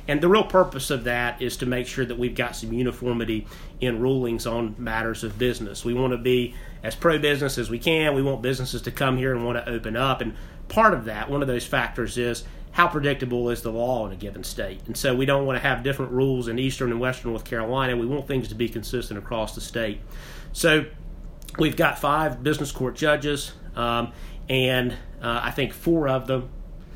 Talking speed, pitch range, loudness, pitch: 220 wpm, 115-135 Hz, -24 LUFS, 125 Hz